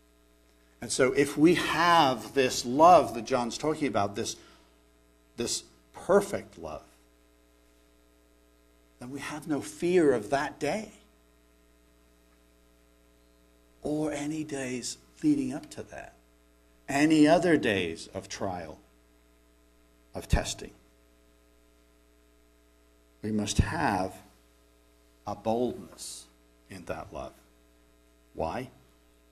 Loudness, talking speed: -28 LUFS, 95 wpm